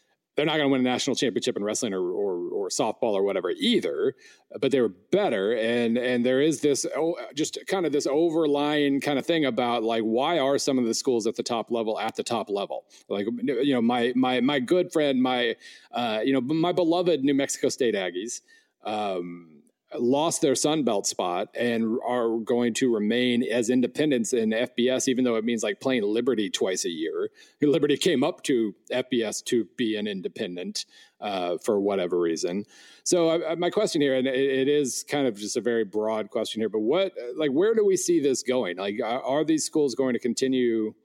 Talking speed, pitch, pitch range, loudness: 205 wpm, 130 Hz, 115-170 Hz, -25 LUFS